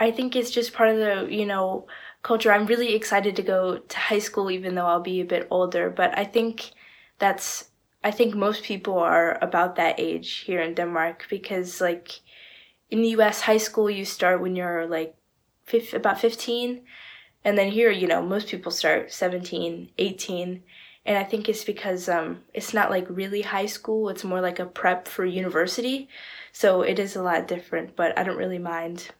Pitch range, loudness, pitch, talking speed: 180-220 Hz, -24 LUFS, 195 Hz, 195 wpm